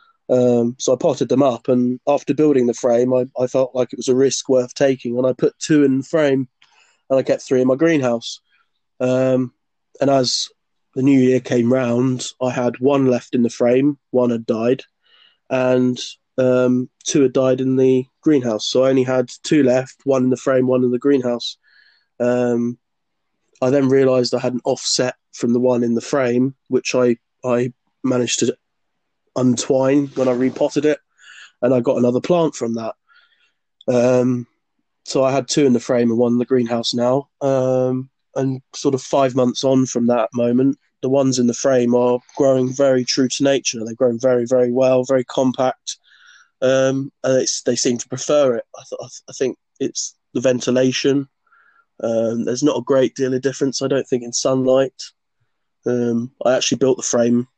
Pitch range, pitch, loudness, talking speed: 125-135 Hz, 130 Hz, -18 LUFS, 190 wpm